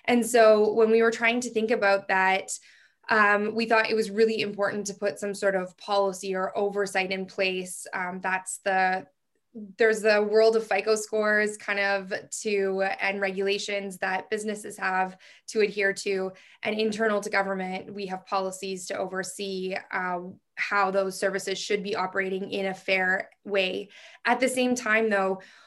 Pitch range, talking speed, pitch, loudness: 190-215 Hz, 170 wpm, 200 Hz, -26 LUFS